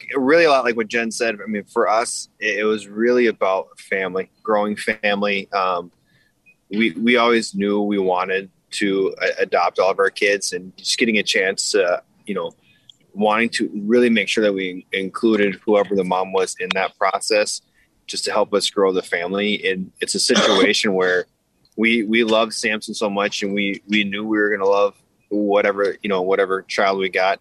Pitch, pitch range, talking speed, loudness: 105 Hz, 100-115 Hz, 195 wpm, -19 LUFS